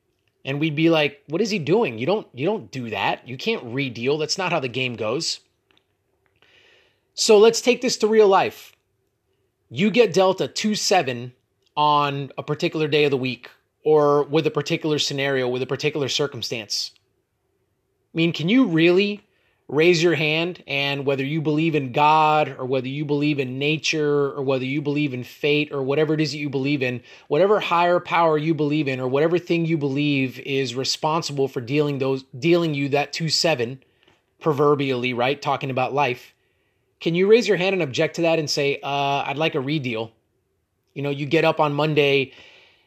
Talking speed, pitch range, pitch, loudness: 190 wpm, 135-165 Hz, 145 Hz, -21 LUFS